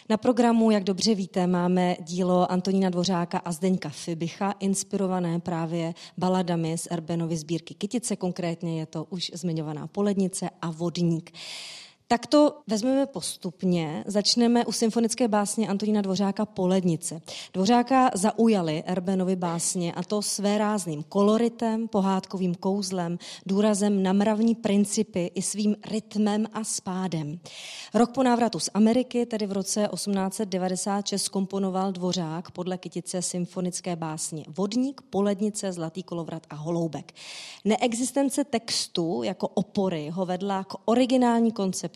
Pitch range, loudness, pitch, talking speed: 175-215 Hz, -26 LUFS, 190 Hz, 125 wpm